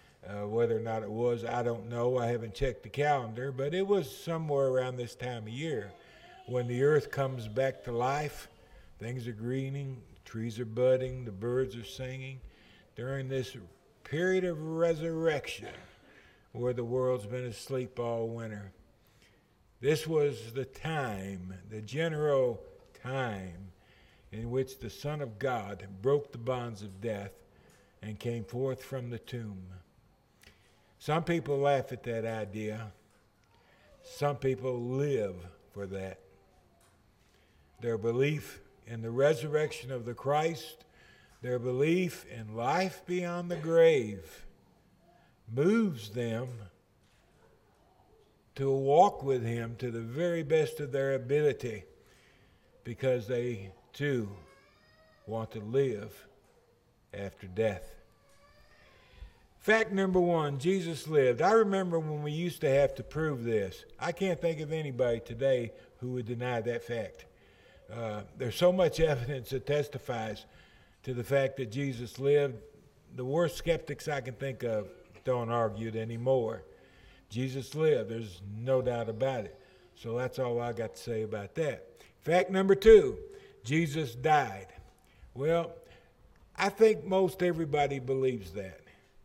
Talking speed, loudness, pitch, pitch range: 135 wpm, -32 LUFS, 125 Hz, 110-145 Hz